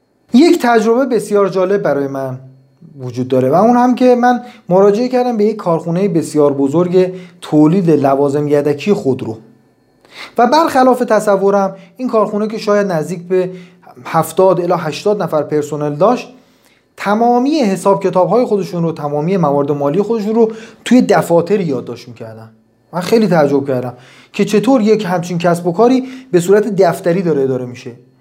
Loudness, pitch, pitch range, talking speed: -13 LUFS, 185 Hz, 145-220 Hz, 150 wpm